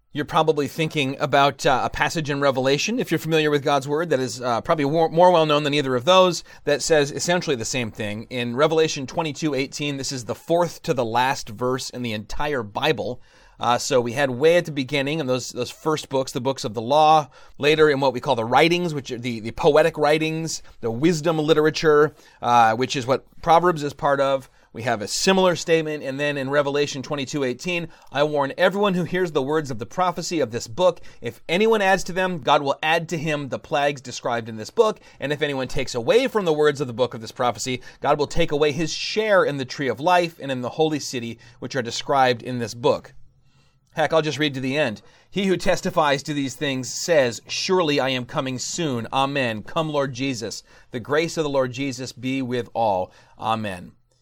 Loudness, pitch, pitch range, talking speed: -22 LUFS, 145 Hz, 130-160 Hz, 220 wpm